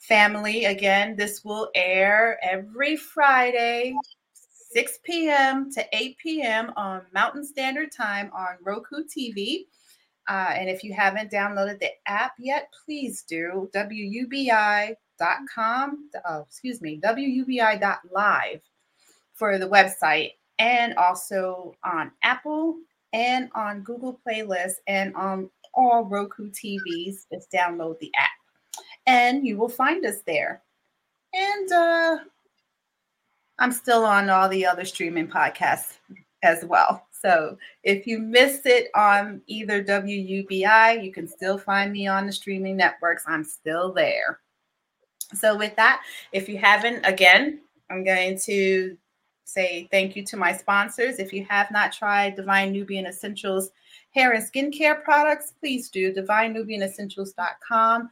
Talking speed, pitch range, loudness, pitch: 130 wpm, 195-255 Hz, -23 LUFS, 210 Hz